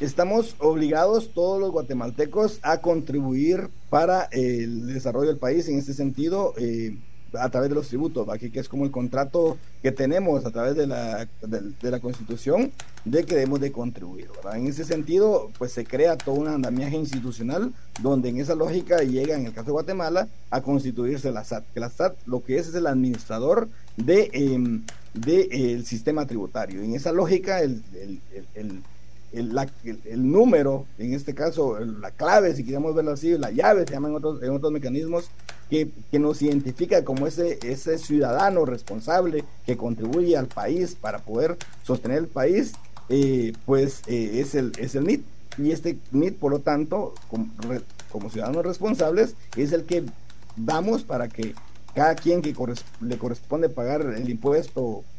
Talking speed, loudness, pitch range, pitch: 180 wpm, -25 LUFS, 120-160 Hz, 135 Hz